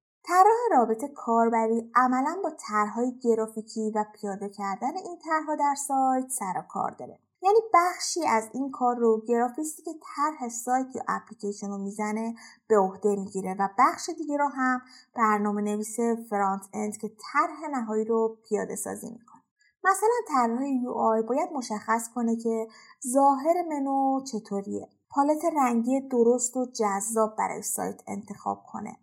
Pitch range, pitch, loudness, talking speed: 215-285 Hz, 240 Hz, -27 LUFS, 145 wpm